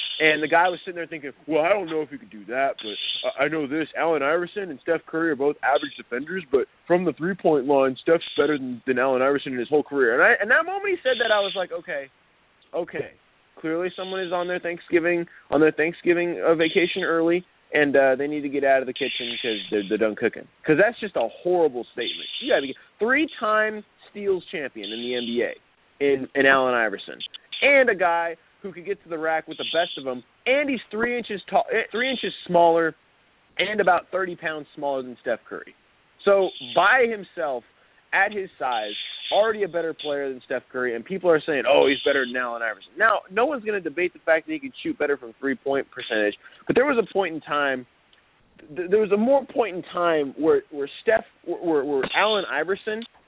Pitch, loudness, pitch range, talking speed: 165 Hz, -23 LUFS, 140-195 Hz, 215 wpm